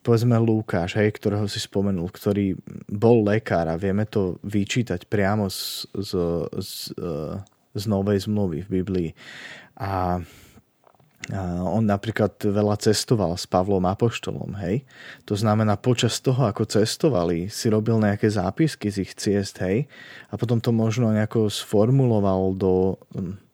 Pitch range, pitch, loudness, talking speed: 95-110 Hz, 105 Hz, -23 LUFS, 135 wpm